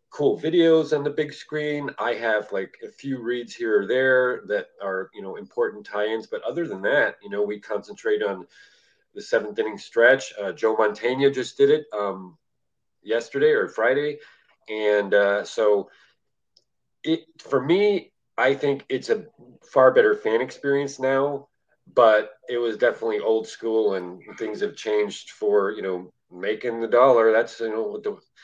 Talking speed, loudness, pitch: 170 wpm, -23 LUFS, 160 Hz